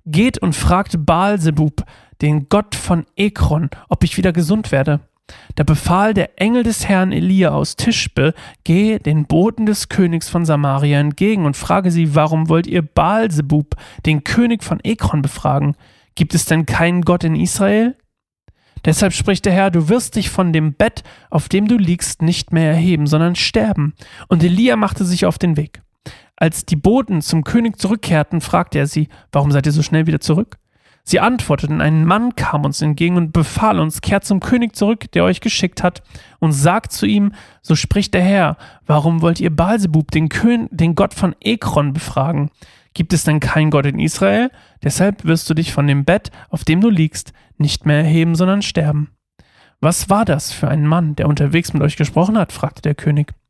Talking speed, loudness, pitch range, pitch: 185 wpm, -16 LUFS, 150-195 Hz, 165 Hz